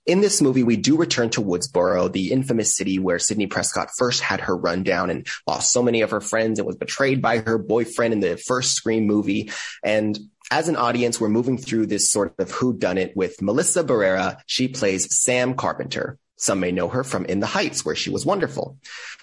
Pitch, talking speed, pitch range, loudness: 115 Hz, 210 wpm, 105-125 Hz, -21 LUFS